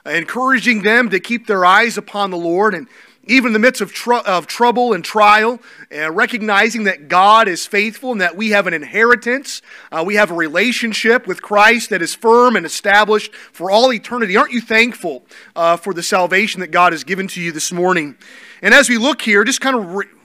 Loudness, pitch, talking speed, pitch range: -14 LUFS, 215 Hz, 210 wpm, 190-240 Hz